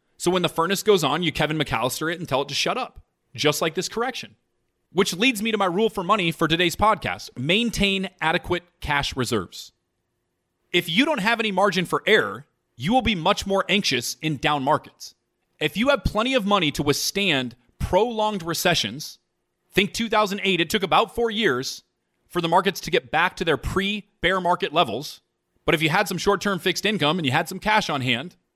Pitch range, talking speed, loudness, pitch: 145-205 Hz, 205 wpm, -22 LUFS, 175 Hz